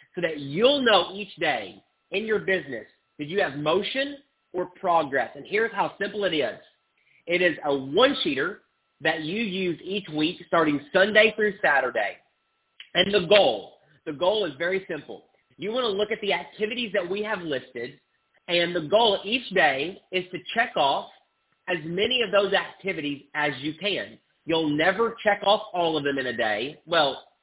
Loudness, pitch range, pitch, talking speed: -24 LUFS, 160-210 Hz, 185 Hz, 175 wpm